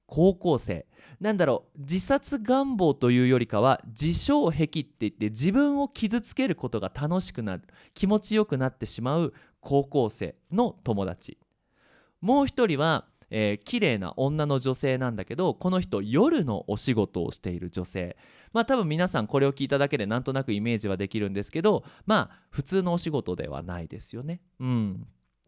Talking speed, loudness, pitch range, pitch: 335 characters per minute, -27 LUFS, 110-180 Hz, 140 Hz